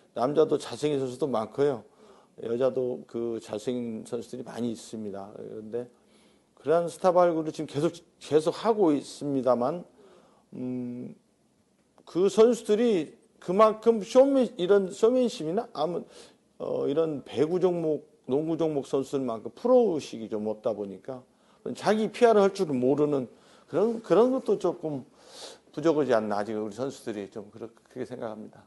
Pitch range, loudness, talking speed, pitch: 120-185 Hz, -27 LUFS, 295 characters per minute, 145 Hz